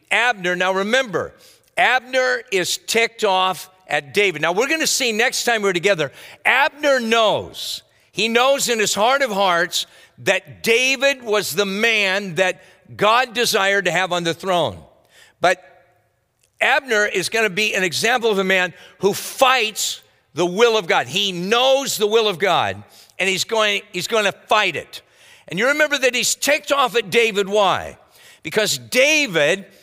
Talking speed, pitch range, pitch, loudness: 165 wpm, 185-245 Hz, 210 Hz, -18 LUFS